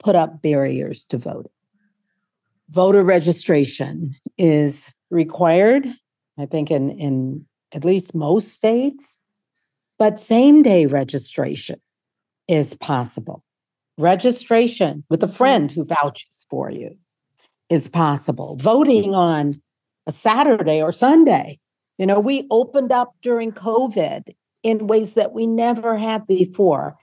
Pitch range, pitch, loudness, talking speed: 150-225 Hz, 180 Hz, -18 LUFS, 115 wpm